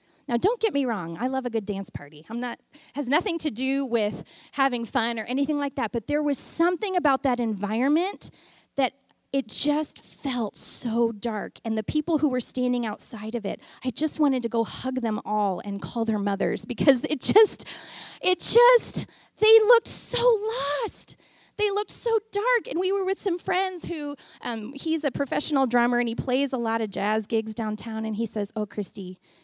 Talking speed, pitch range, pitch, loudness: 200 wpm, 225-310 Hz, 260 Hz, -25 LUFS